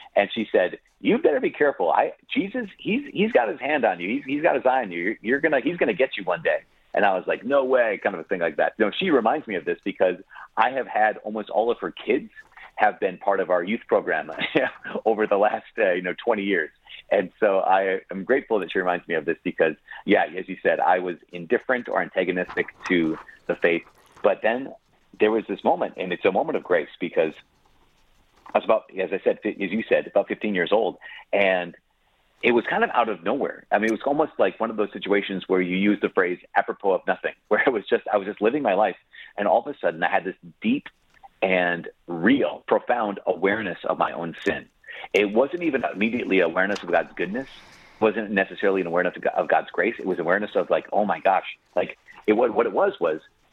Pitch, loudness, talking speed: 105 Hz, -24 LUFS, 235 wpm